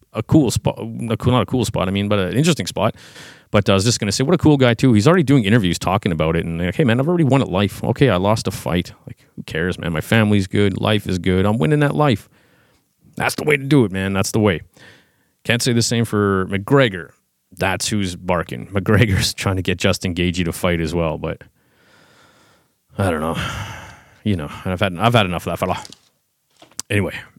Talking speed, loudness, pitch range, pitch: 230 wpm, -18 LUFS, 90-120 Hz, 100 Hz